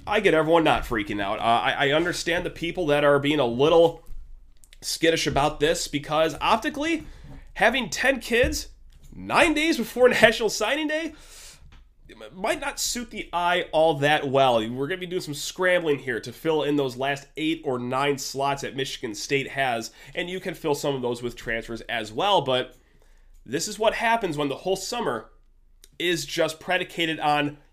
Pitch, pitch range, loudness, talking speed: 155 Hz, 135-185 Hz, -24 LUFS, 180 wpm